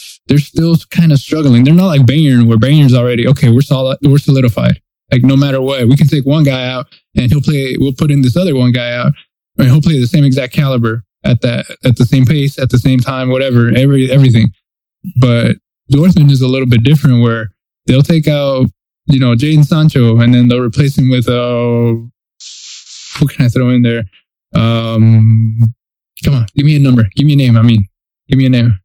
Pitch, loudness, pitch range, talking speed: 130 Hz, -10 LUFS, 120-140 Hz, 215 wpm